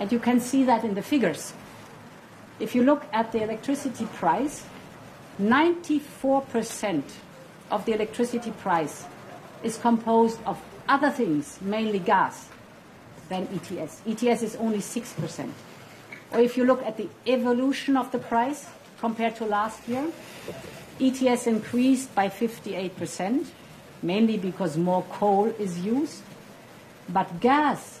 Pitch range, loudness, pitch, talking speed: 200-255 Hz, -26 LUFS, 225 Hz, 125 wpm